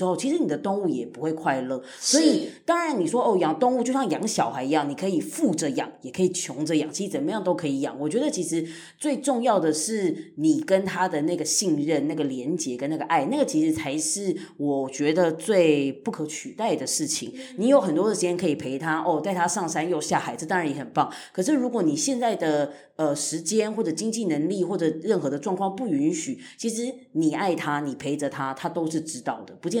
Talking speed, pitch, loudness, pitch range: 330 characters per minute, 180 Hz, -25 LUFS, 155-255 Hz